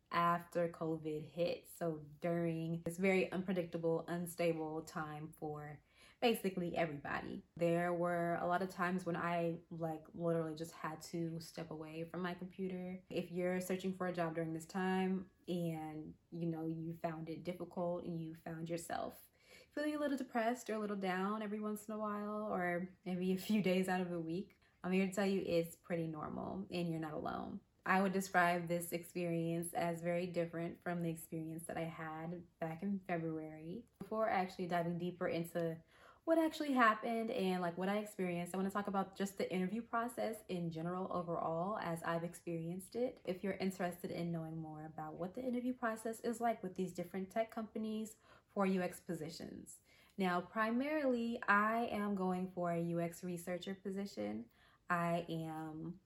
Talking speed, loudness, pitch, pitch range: 175 wpm, -40 LUFS, 175 Hz, 165-195 Hz